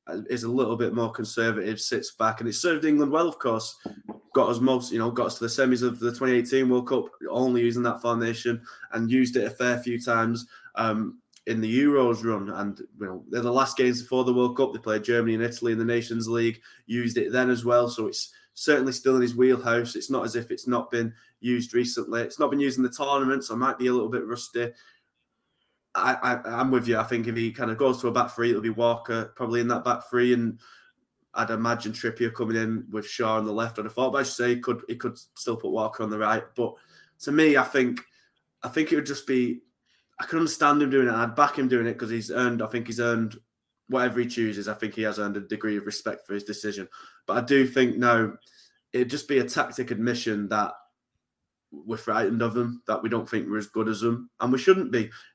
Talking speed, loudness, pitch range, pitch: 245 wpm, -26 LUFS, 115-125 Hz, 120 Hz